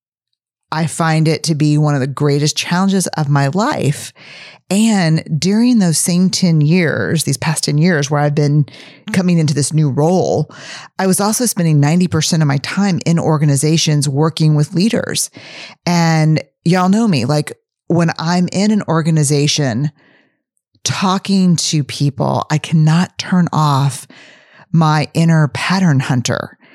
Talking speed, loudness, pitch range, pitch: 145 wpm, -14 LUFS, 145-180 Hz, 160 Hz